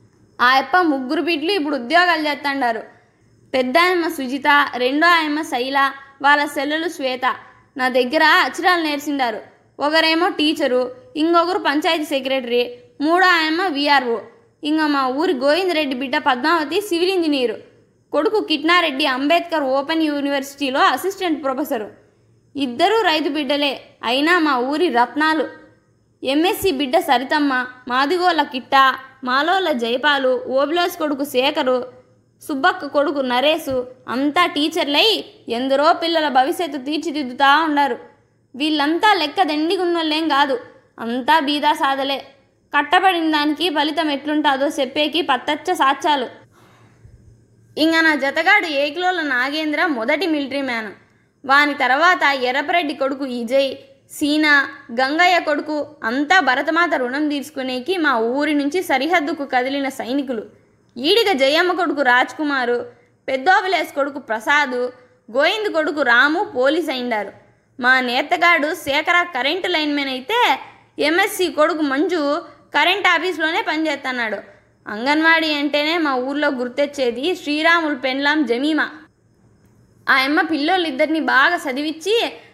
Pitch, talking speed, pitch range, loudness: 295 Hz, 110 wpm, 270-335 Hz, -18 LUFS